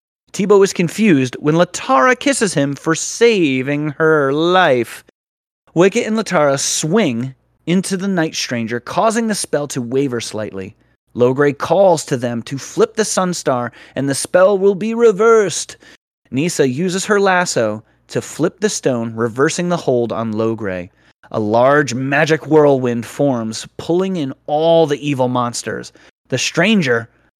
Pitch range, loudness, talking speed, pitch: 125-185 Hz, -16 LUFS, 140 wpm, 150 Hz